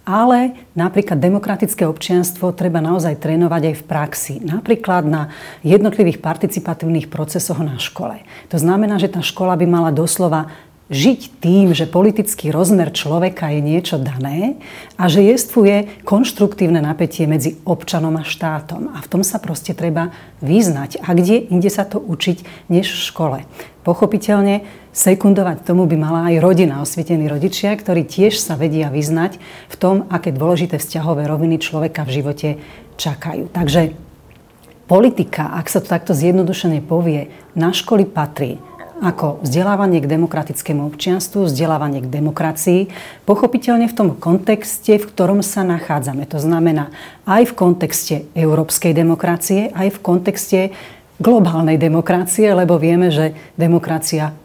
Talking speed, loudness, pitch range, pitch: 140 wpm, -16 LUFS, 160-195 Hz, 175 Hz